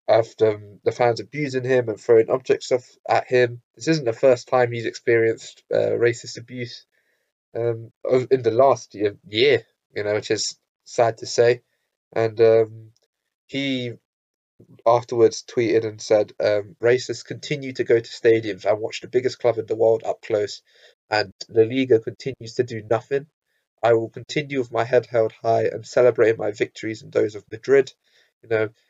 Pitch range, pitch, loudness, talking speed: 115-145 Hz, 120 Hz, -22 LUFS, 175 wpm